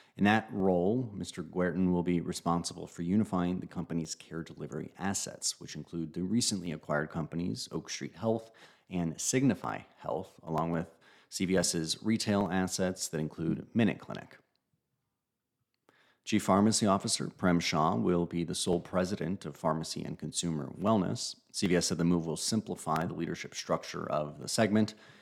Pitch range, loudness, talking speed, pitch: 85-100 Hz, -32 LUFS, 150 wpm, 90 Hz